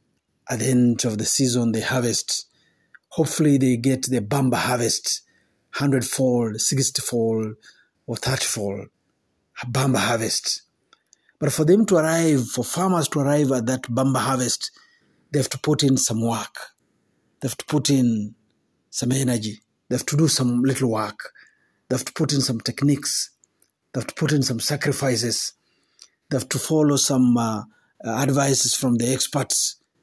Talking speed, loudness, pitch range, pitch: 165 wpm, -21 LUFS, 120-140 Hz, 130 Hz